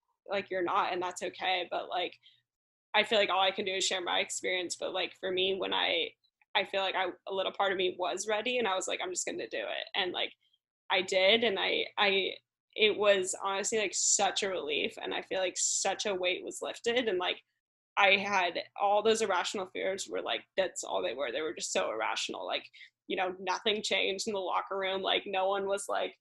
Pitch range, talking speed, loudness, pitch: 185-215 Hz, 235 wpm, -31 LUFS, 195 Hz